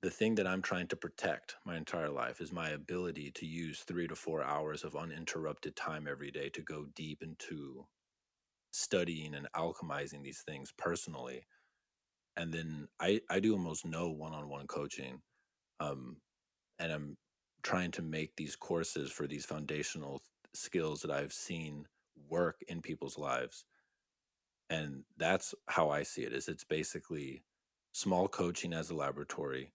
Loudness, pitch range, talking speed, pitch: -39 LUFS, 70-80 Hz, 155 wpm, 75 Hz